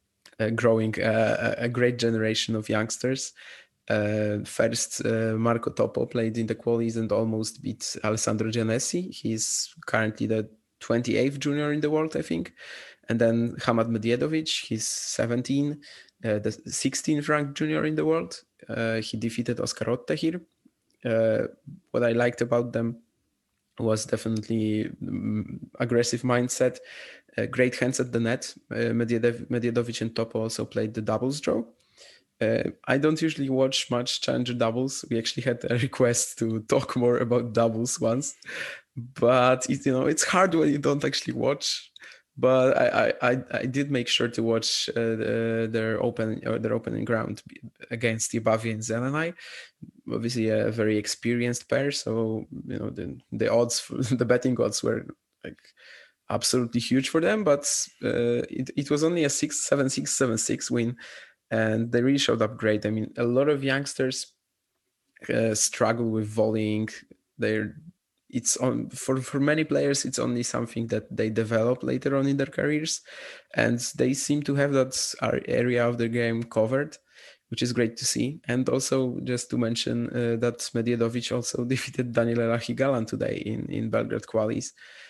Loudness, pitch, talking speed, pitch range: -26 LUFS, 120 Hz, 160 wpm, 115-130 Hz